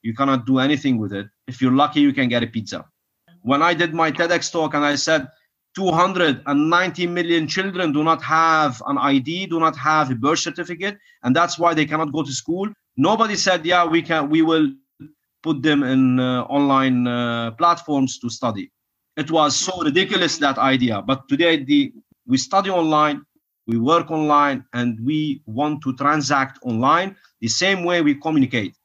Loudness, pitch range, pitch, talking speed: -19 LUFS, 135-170 Hz, 150 Hz, 180 wpm